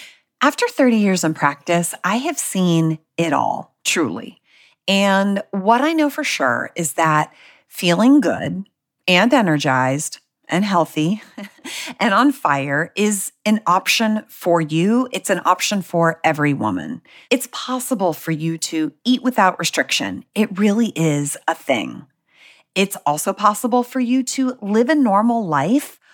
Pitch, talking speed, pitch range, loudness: 195 Hz, 140 wpm, 165-245 Hz, -18 LUFS